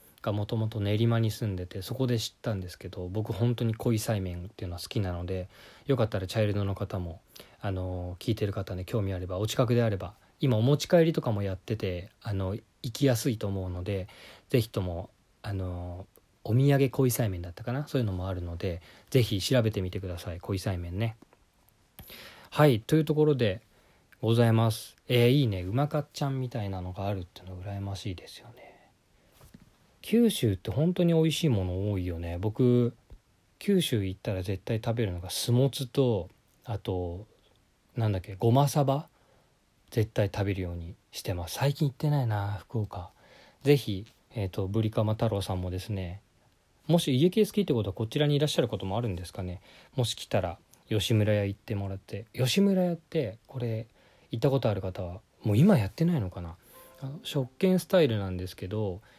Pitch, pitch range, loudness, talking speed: 110 Hz, 95-130 Hz, -29 LUFS, 370 characters per minute